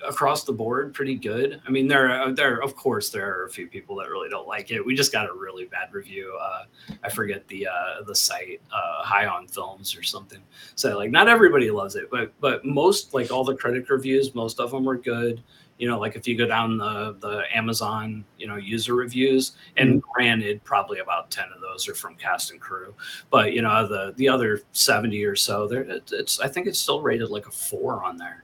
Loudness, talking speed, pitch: -23 LUFS, 230 wpm, 130 Hz